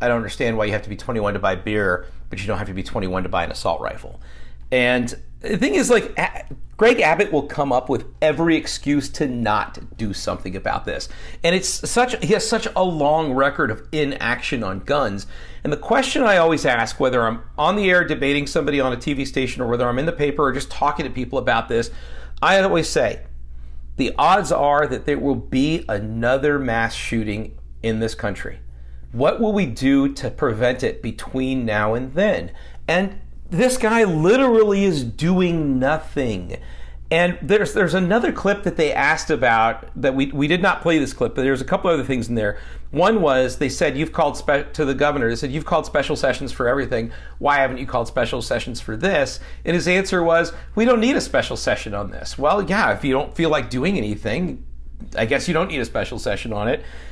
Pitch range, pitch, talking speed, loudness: 105-160 Hz, 130 Hz, 210 wpm, -20 LUFS